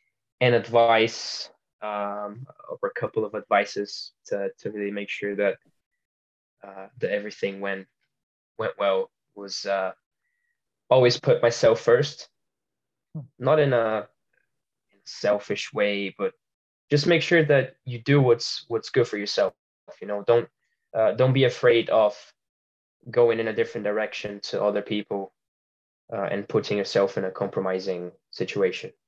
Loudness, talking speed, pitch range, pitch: -24 LUFS, 140 wpm, 100-140 Hz, 110 Hz